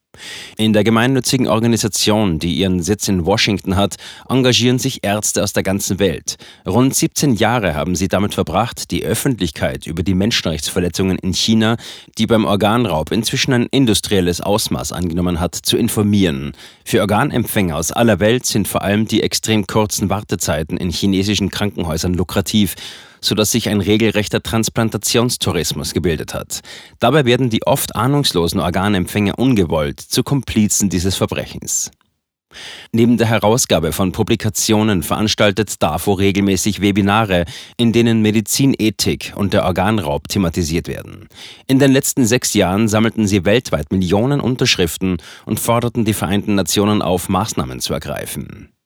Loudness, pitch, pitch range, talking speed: -16 LUFS, 105 Hz, 95-115 Hz, 140 wpm